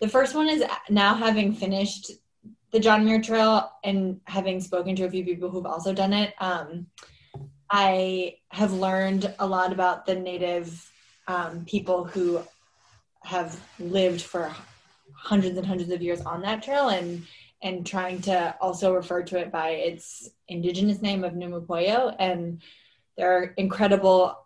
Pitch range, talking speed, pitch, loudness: 175-200 Hz, 155 wpm, 185 Hz, -25 LUFS